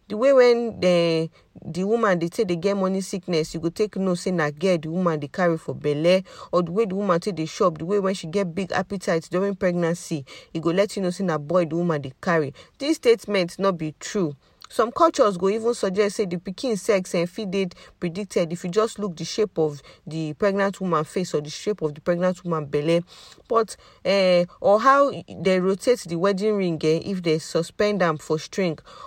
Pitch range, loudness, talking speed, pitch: 165-200 Hz, -23 LUFS, 225 wpm, 185 Hz